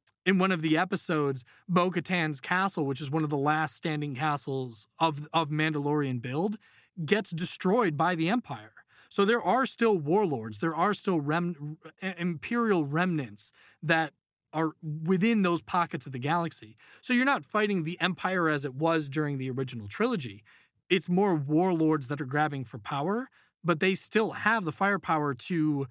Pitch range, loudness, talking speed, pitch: 150-185 Hz, -28 LUFS, 165 wpm, 165 Hz